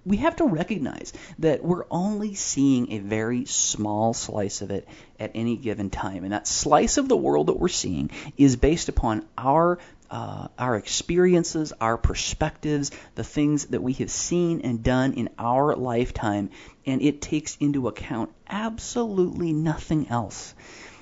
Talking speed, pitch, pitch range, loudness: 155 wpm, 135 Hz, 110-160 Hz, -25 LUFS